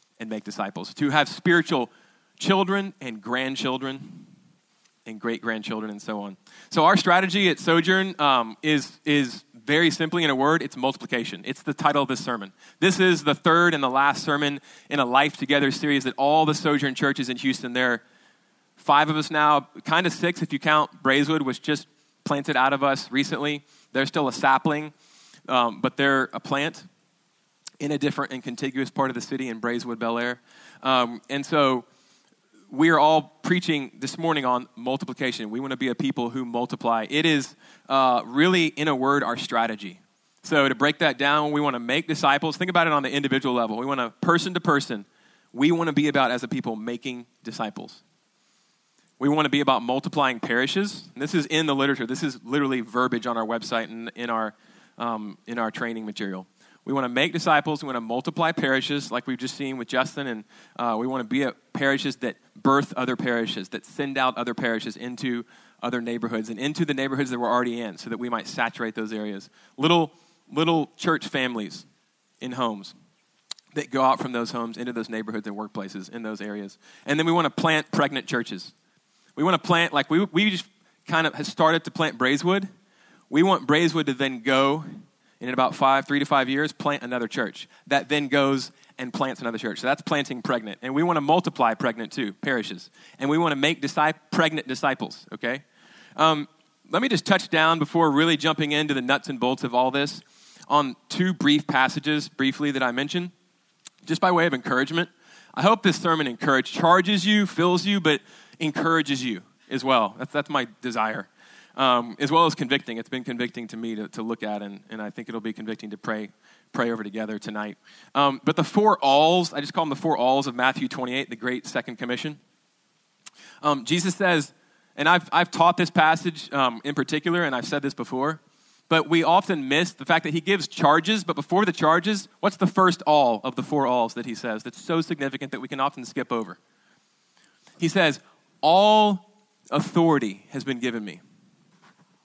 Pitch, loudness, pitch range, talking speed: 140 Hz, -24 LUFS, 125-160 Hz, 200 wpm